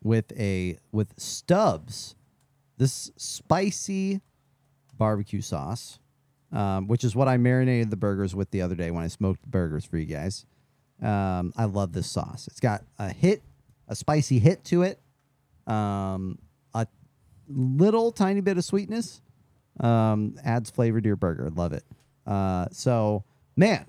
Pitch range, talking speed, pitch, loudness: 100-140 Hz, 150 wpm, 115 Hz, -26 LUFS